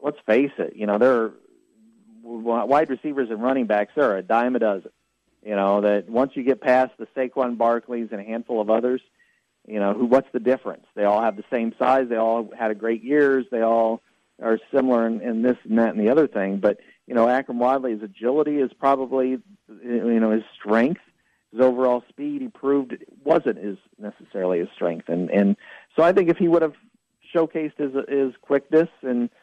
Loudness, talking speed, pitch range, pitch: -22 LUFS, 205 wpm, 110-135 Hz, 125 Hz